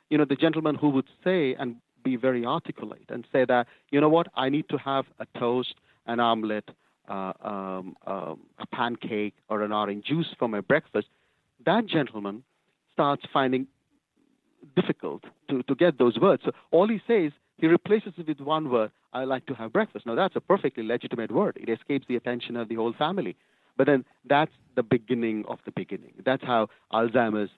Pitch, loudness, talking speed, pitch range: 130 Hz, -27 LUFS, 190 wpm, 115-150 Hz